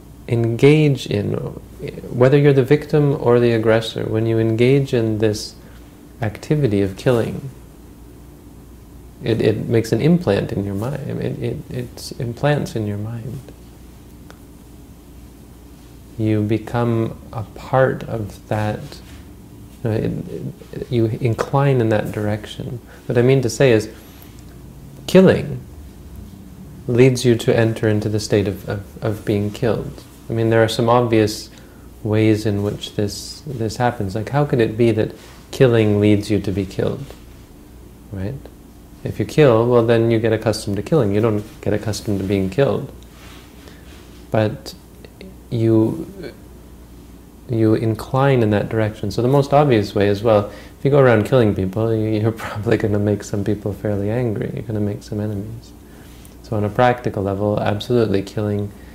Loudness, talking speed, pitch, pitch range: -18 LUFS, 155 wpm, 110 Hz, 100-120 Hz